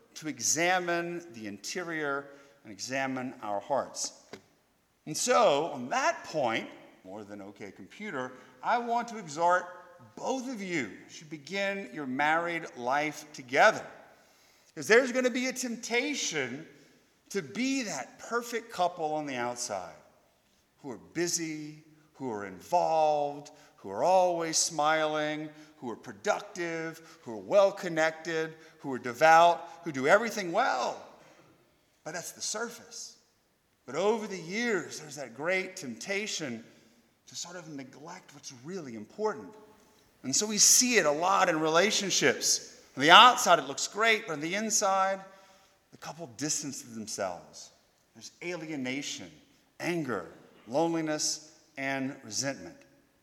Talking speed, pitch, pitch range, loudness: 130 wpm, 160 Hz, 135-195 Hz, -28 LUFS